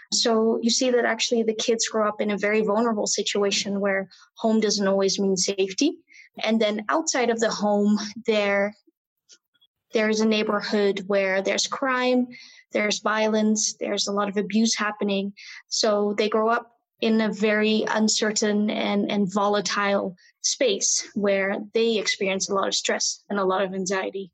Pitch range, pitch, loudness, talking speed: 205-225 Hz, 215 Hz, -23 LUFS, 160 wpm